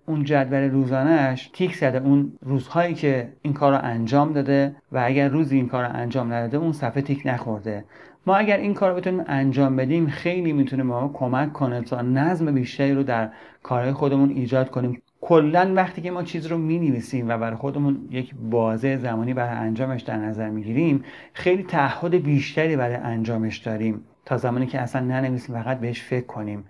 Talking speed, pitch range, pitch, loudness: 180 wpm, 120-150 Hz, 135 Hz, -23 LUFS